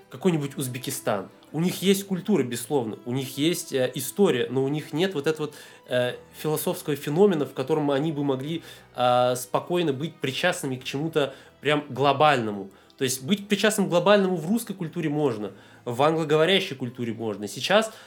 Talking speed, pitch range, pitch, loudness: 165 wpm, 130-175 Hz, 150 Hz, -25 LUFS